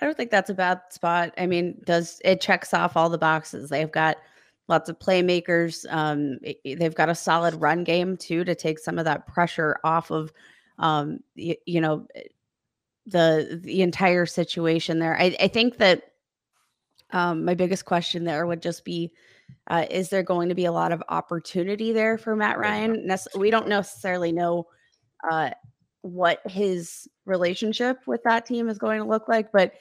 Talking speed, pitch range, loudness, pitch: 180 wpm, 165-190 Hz, -24 LUFS, 175 Hz